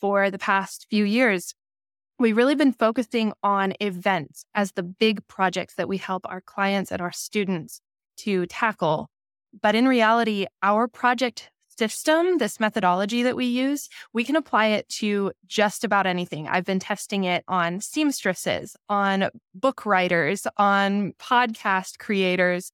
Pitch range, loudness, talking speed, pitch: 185-230 Hz, -23 LUFS, 150 wpm, 200 Hz